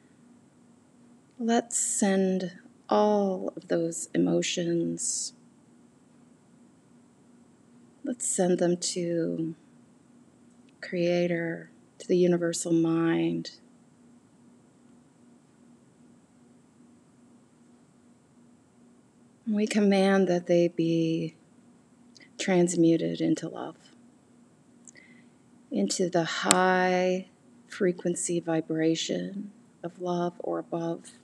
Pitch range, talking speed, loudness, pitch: 165-210 Hz, 60 wpm, -27 LUFS, 180 Hz